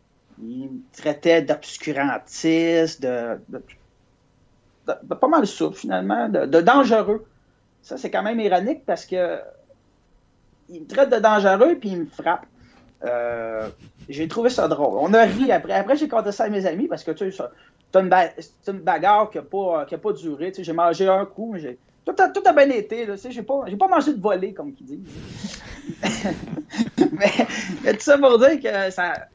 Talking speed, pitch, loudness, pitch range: 190 wpm, 210 Hz, -20 LUFS, 170-265 Hz